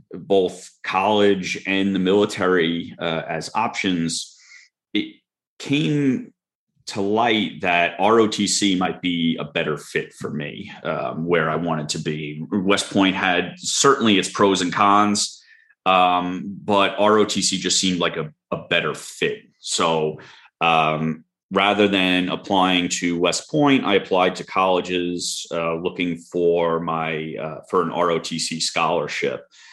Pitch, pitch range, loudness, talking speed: 90 Hz, 85-100 Hz, -20 LUFS, 135 wpm